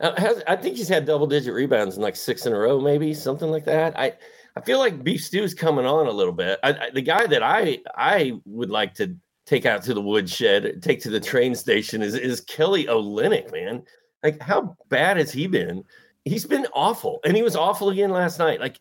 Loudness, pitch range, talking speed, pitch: -22 LUFS, 145-230 Hz, 225 wpm, 165 Hz